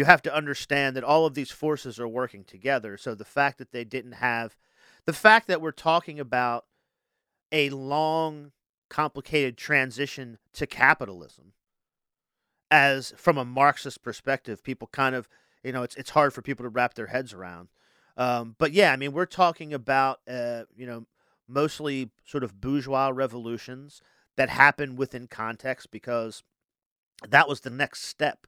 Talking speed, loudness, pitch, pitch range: 160 wpm, -25 LUFS, 135 Hz, 120-145 Hz